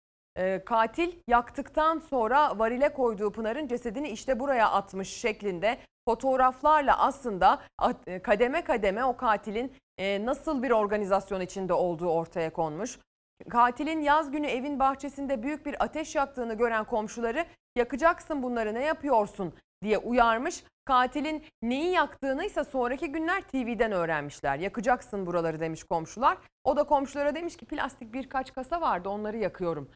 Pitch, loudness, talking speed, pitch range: 245 Hz, -28 LUFS, 130 wpm, 210-290 Hz